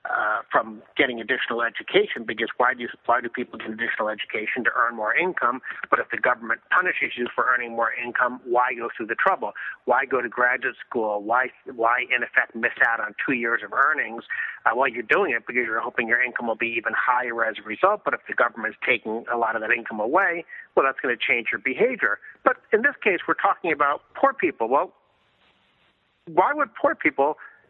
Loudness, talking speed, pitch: -23 LUFS, 220 wpm, 125 Hz